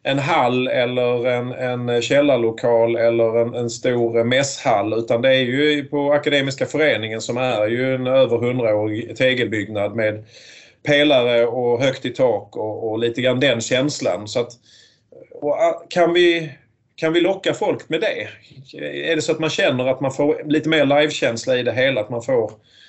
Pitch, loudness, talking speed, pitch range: 130 Hz, -19 LUFS, 175 wpm, 120-150 Hz